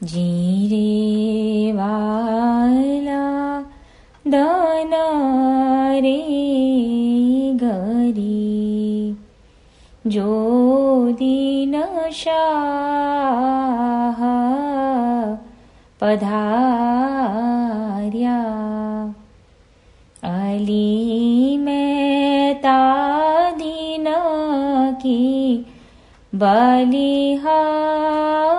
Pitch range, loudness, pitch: 220-280 Hz, -18 LUFS, 255 Hz